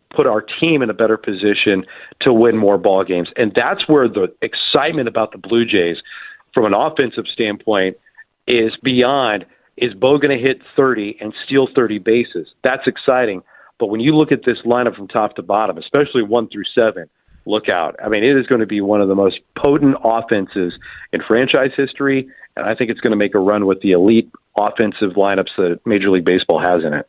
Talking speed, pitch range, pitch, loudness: 205 wpm, 100-130 Hz, 110 Hz, -16 LUFS